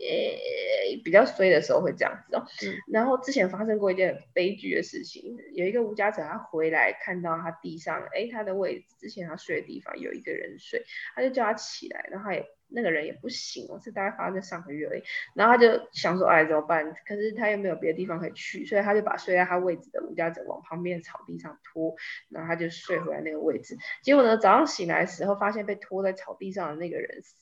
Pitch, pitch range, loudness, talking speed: 200 Hz, 175-270 Hz, -27 LUFS, 360 characters per minute